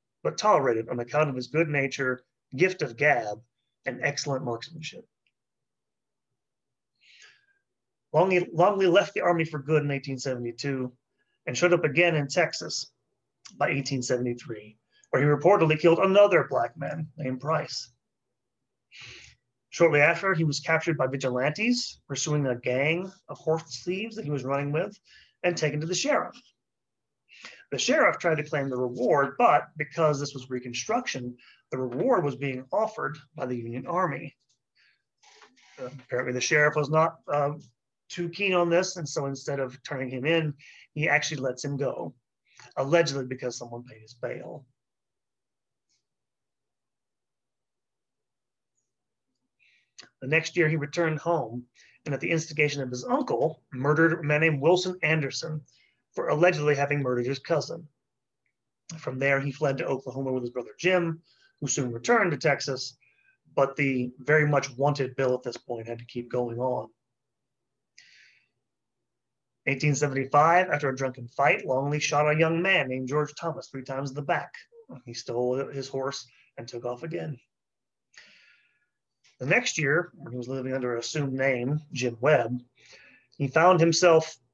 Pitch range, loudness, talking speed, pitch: 125-160 Hz, -26 LUFS, 150 wpm, 140 Hz